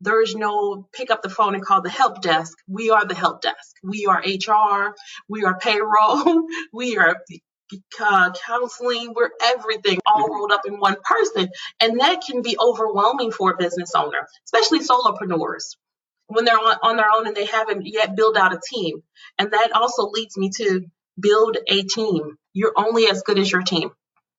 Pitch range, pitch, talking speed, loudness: 195-230 Hz, 210 Hz, 180 wpm, -19 LUFS